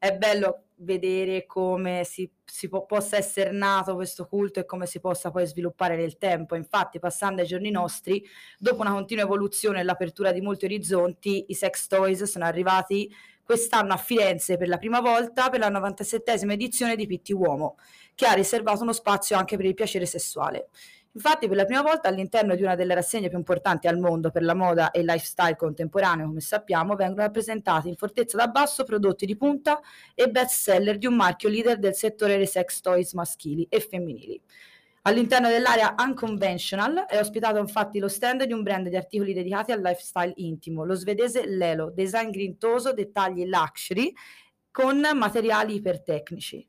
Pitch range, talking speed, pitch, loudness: 180-220 Hz, 175 wpm, 195 Hz, -25 LUFS